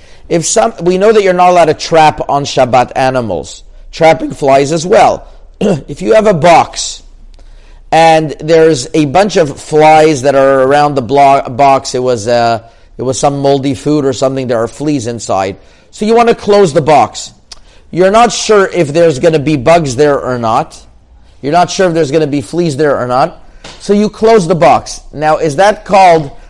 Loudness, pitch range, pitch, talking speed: -9 LUFS, 135-175 Hz, 155 Hz, 195 wpm